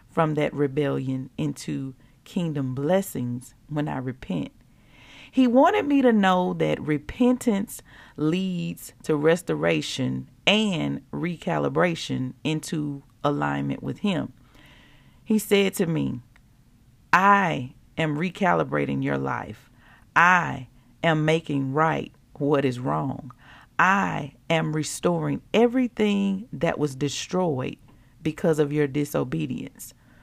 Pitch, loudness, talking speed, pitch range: 145 Hz, -24 LUFS, 105 wpm, 130-170 Hz